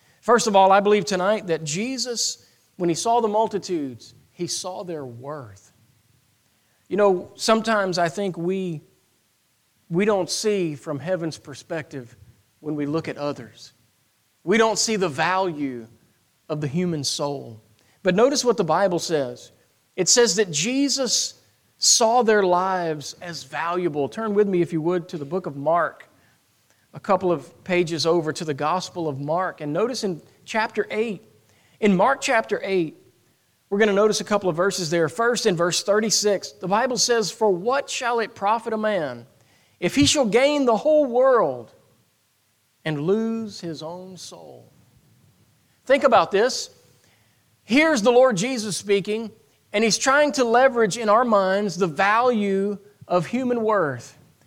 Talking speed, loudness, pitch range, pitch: 160 wpm, -21 LUFS, 150-220 Hz, 185 Hz